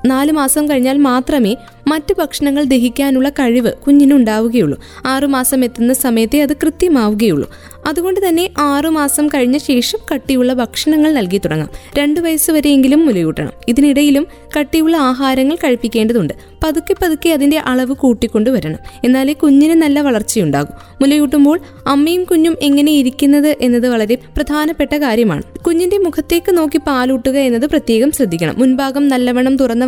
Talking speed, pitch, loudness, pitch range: 120 wpm, 280 Hz, -13 LUFS, 250-305 Hz